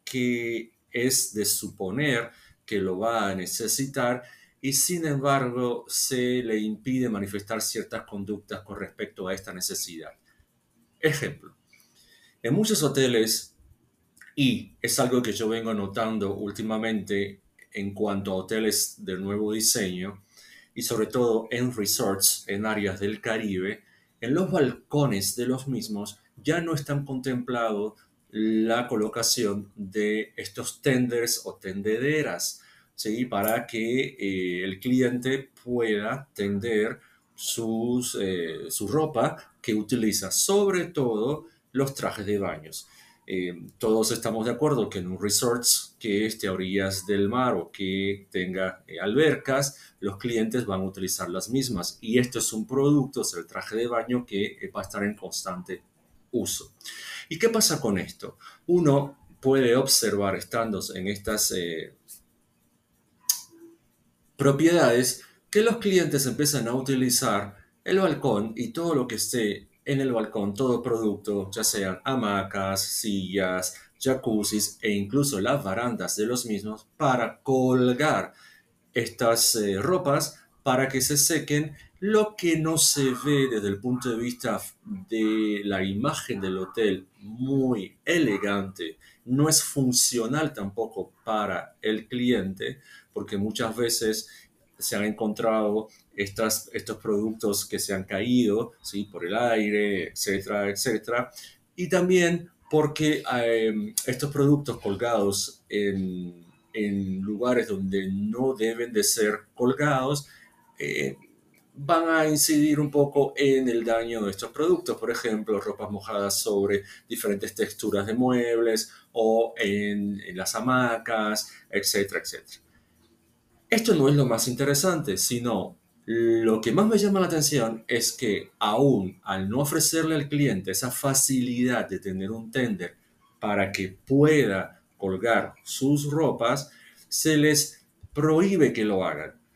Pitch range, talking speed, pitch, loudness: 100-135 Hz, 135 wpm, 115 Hz, -26 LUFS